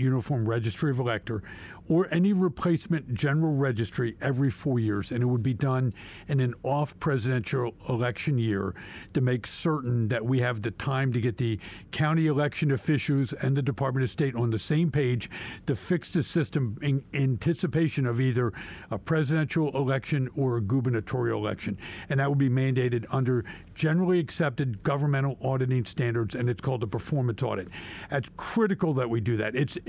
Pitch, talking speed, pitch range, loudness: 130 Hz, 170 wpm, 120-145 Hz, -27 LUFS